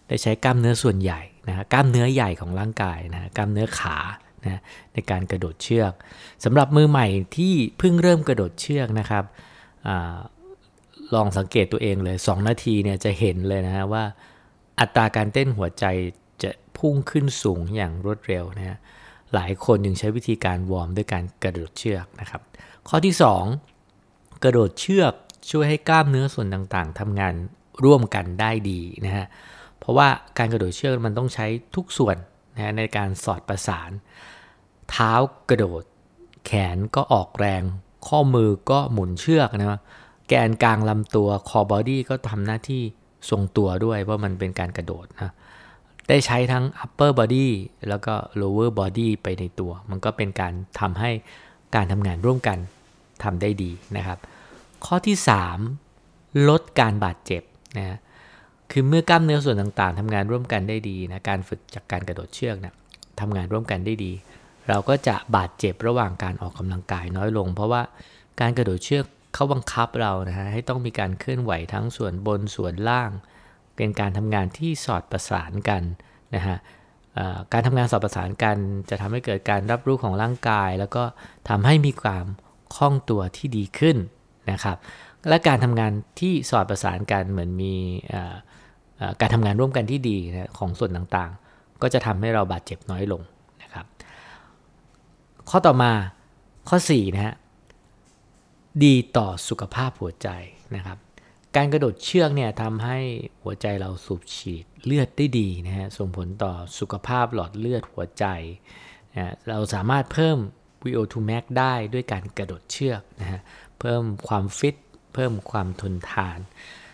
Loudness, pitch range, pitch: -23 LUFS, 95-125 Hz, 105 Hz